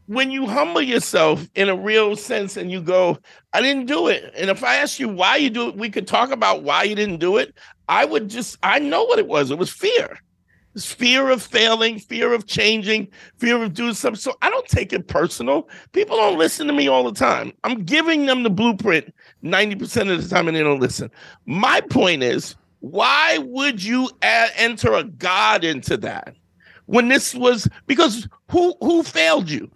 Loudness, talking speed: -18 LUFS, 210 wpm